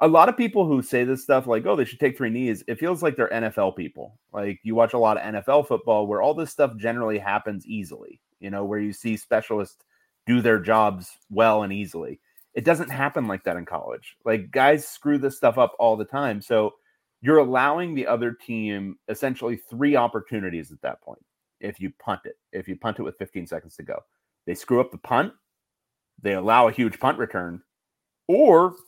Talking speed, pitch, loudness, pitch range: 210 wpm, 115 Hz, -23 LUFS, 105-140 Hz